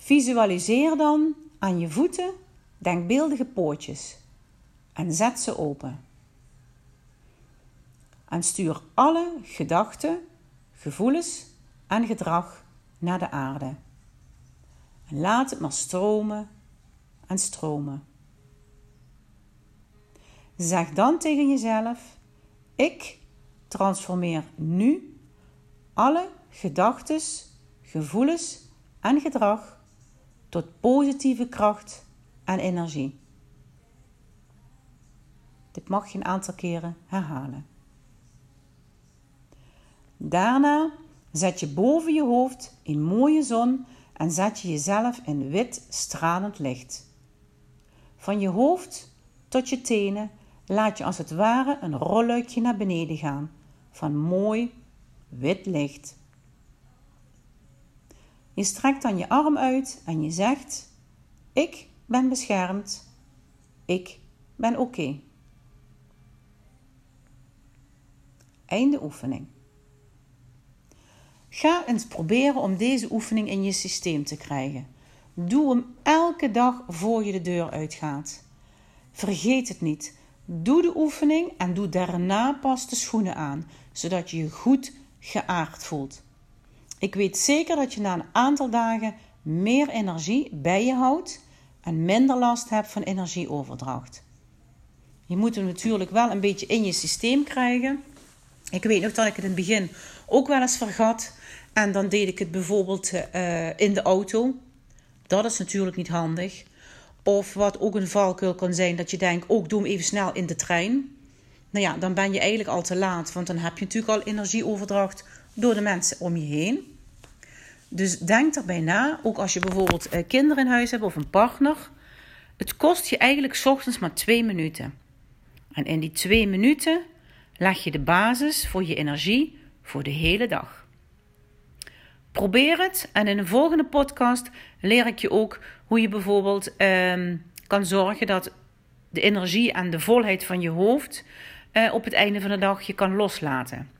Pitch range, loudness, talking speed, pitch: 145-235 Hz, -24 LUFS, 135 wpm, 190 Hz